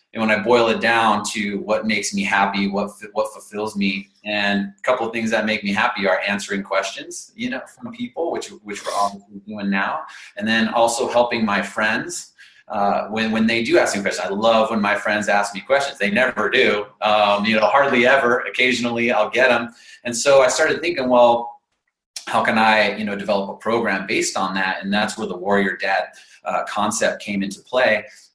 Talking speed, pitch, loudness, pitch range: 210 wpm, 105 Hz, -19 LUFS, 100-120 Hz